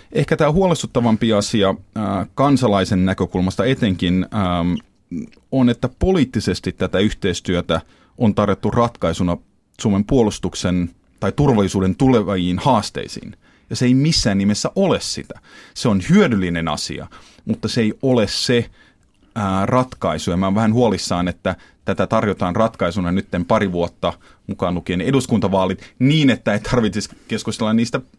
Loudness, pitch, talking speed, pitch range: -19 LUFS, 100 Hz, 125 wpm, 95-115 Hz